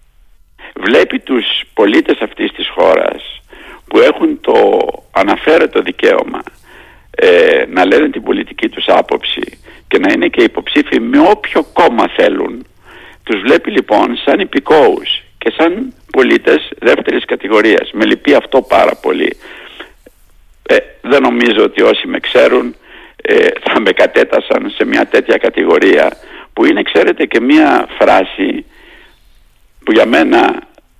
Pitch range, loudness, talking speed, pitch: 325-455 Hz, -11 LUFS, 130 wpm, 375 Hz